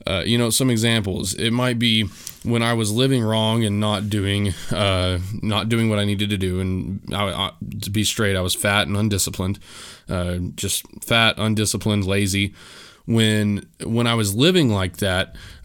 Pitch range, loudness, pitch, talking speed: 95-115 Hz, -20 LUFS, 105 Hz, 180 wpm